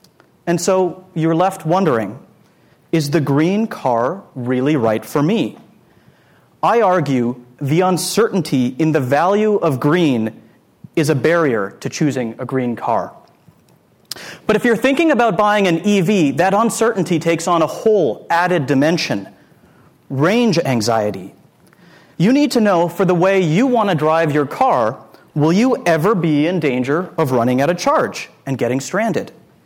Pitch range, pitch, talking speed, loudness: 140-195 Hz, 165 Hz, 150 wpm, -16 LUFS